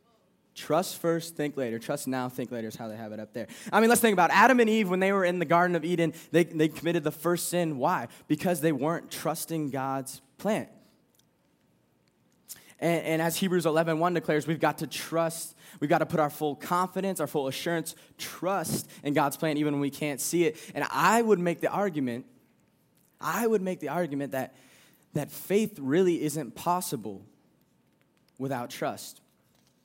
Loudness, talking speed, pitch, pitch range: -28 LUFS, 190 wpm, 160 Hz, 145-175 Hz